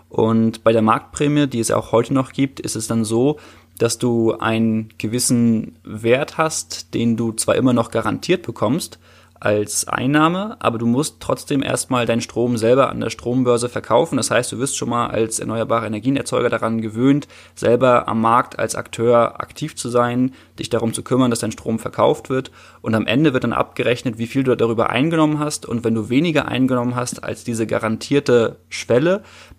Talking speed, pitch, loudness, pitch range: 185 wpm, 120 Hz, -19 LUFS, 115-130 Hz